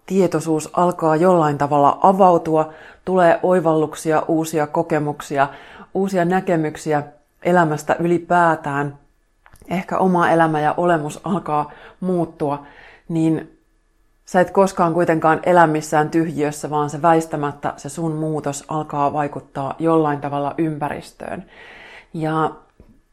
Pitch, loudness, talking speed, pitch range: 160 Hz, -19 LUFS, 105 wpm, 150-175 Hz